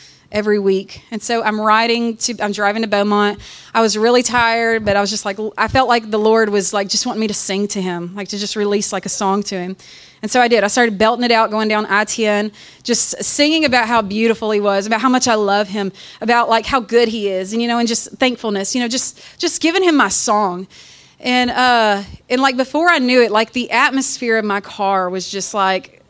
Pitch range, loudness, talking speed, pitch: 205-240 Hz, -16 LUFS, 240 wpm, 220 Hz